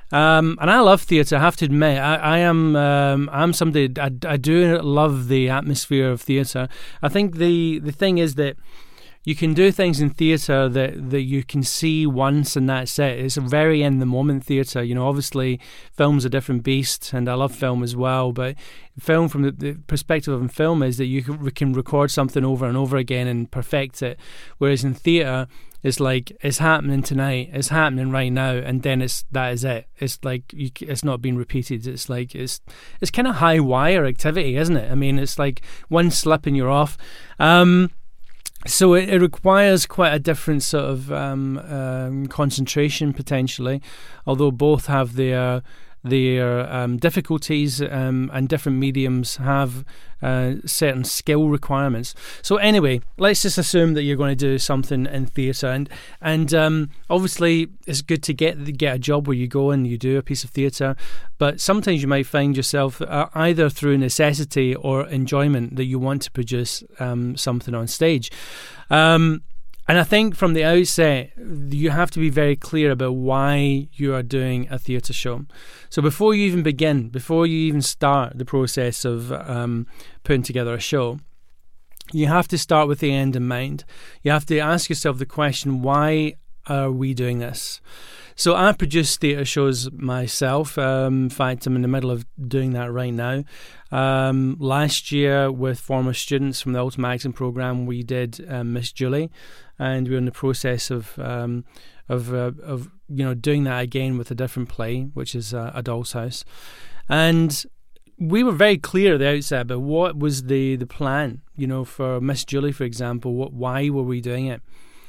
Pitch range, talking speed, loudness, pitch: 130-155 Hz, 190 wpm, -20 LUFS, 140 Hz